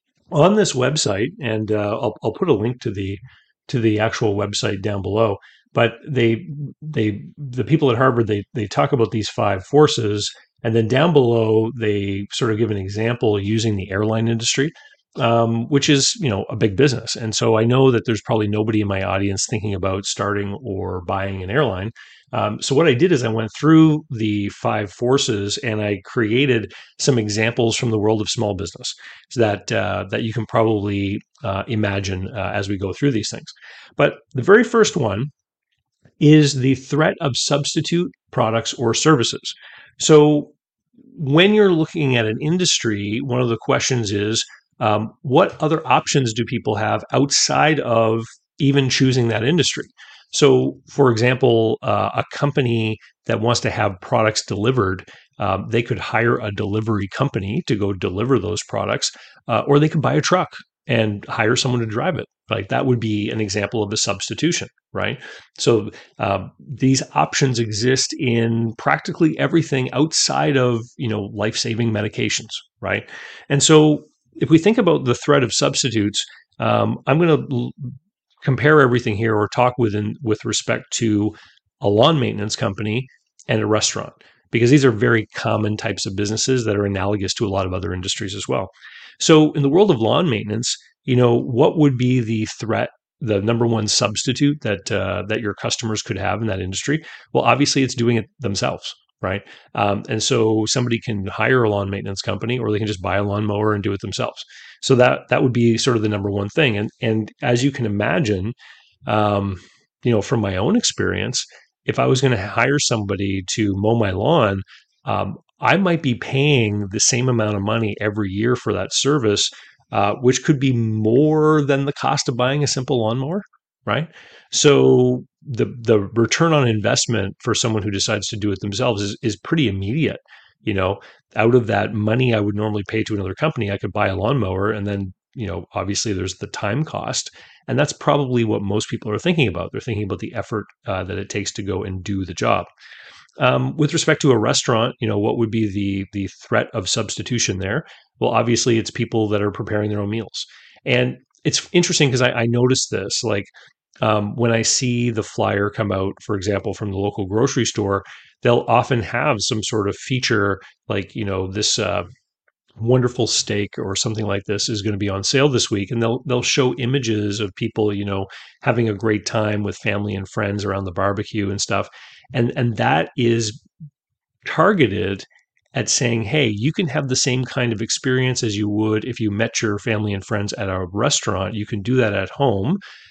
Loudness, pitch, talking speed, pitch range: -19 LUFS, 115 Hz, 190 wpm, 105-130 Hz